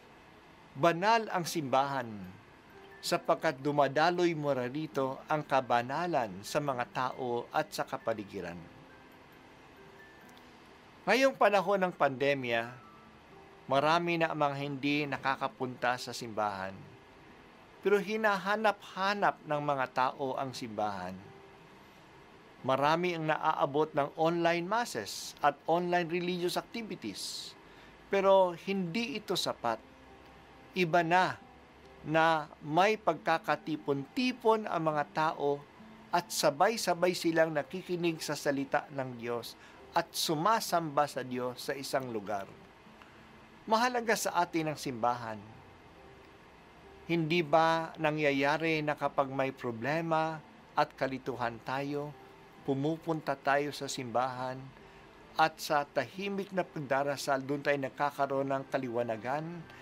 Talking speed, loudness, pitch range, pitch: 100 wpm, -32 LUFS, 130-170 Hz, 145 Hz